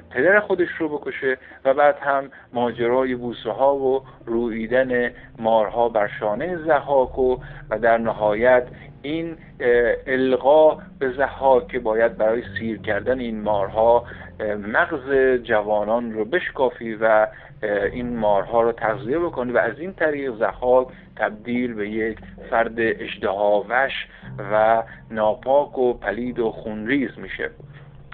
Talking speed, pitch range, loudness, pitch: 125 wpm, 110-135 Hz, -21 LUFS, 120 Hz